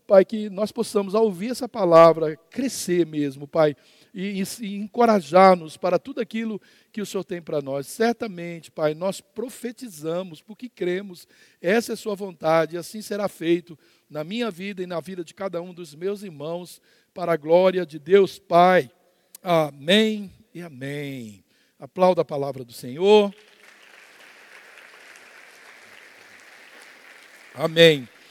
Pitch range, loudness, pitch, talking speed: 165-210 Hz, -22 LUFS, 180 Hz, 140 wpm